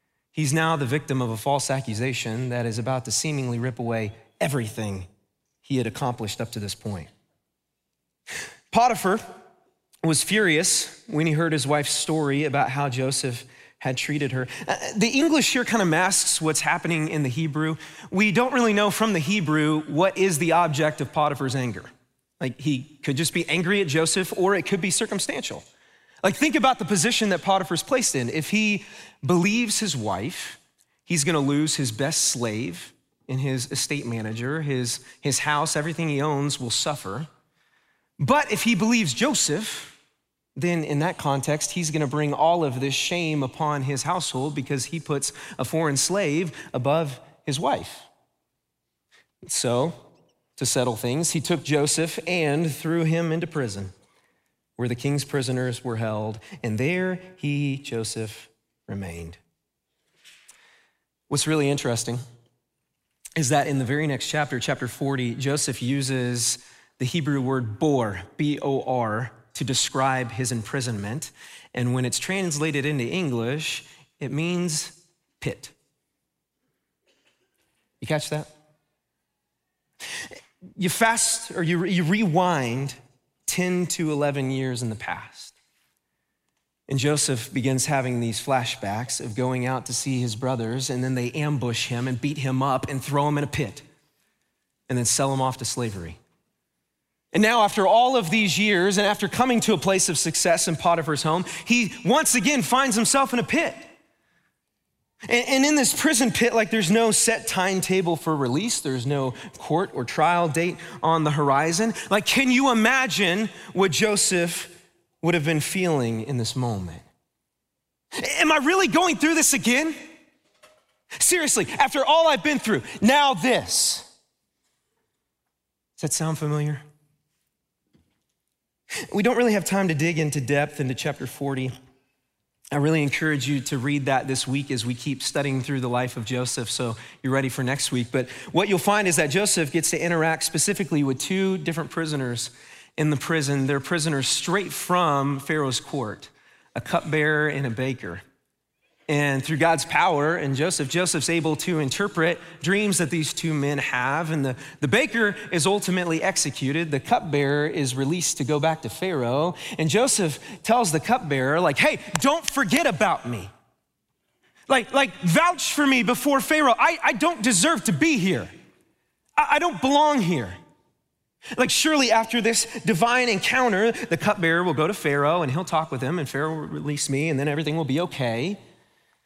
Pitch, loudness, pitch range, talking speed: 155 Hz, -23 LUFS, 135-185 Hz, 160 wpm